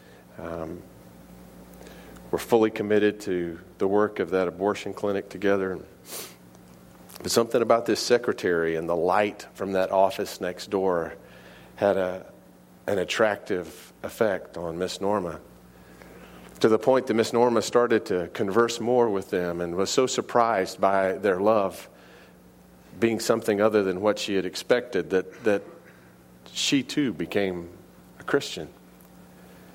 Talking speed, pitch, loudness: 135 wpm, 95 Hz, -25 LUFS